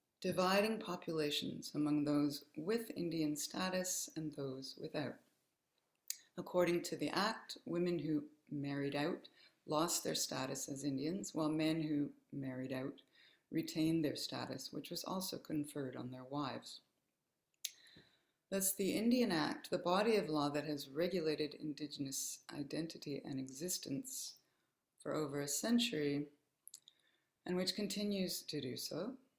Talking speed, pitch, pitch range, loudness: 130 wpm, 155 Hz, 145-185 Hz, -40 LUFS